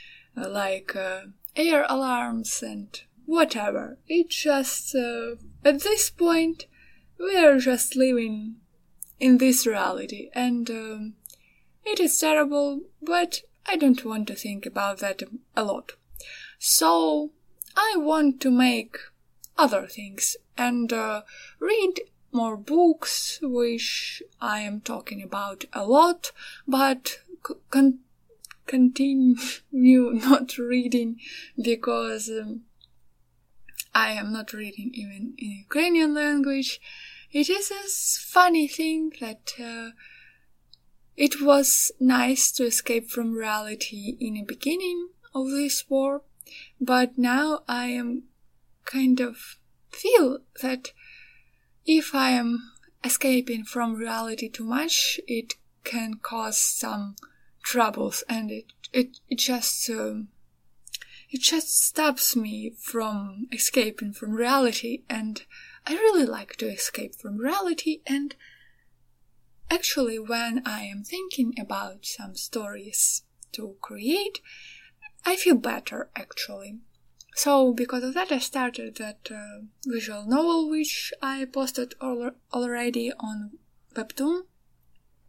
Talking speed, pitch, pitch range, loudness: 115 wpm, 250 Hz, 225-290 Hz, -25 LUFS